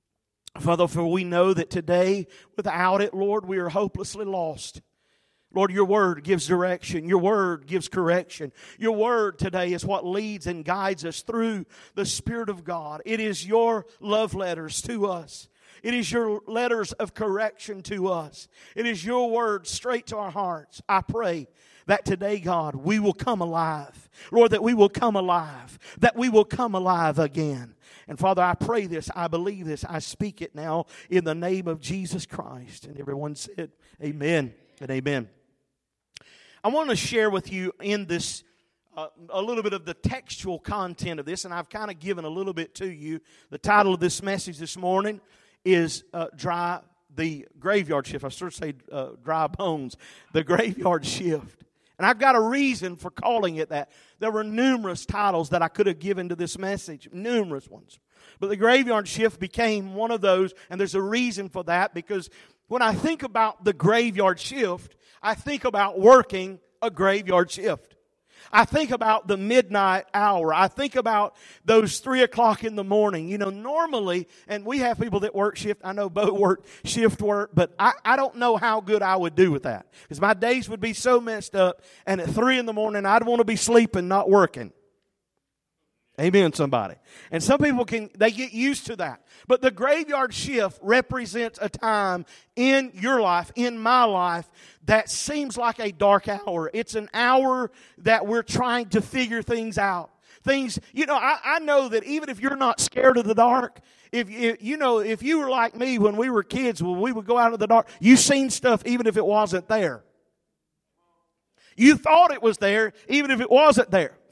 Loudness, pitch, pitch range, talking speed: -23 LUFS, 200 Hz, 175-230 Hz, 195 wpm